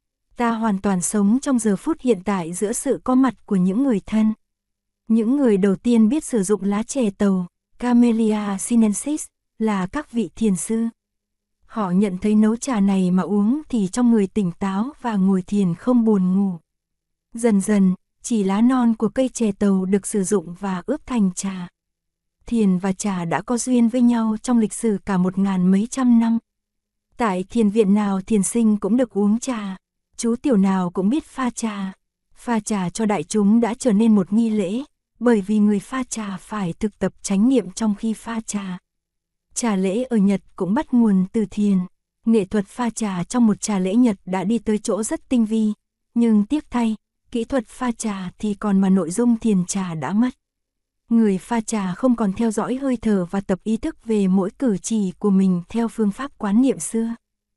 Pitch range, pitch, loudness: 195-235 Hz, 215 Hz, -20 LUFS